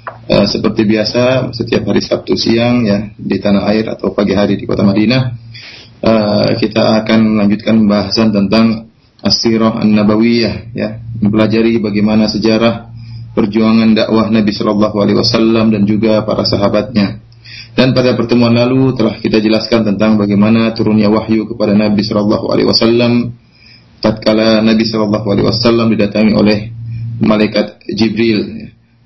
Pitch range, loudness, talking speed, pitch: 105-115 Hz, -11 LUFS, 135 wpm, 110 Hz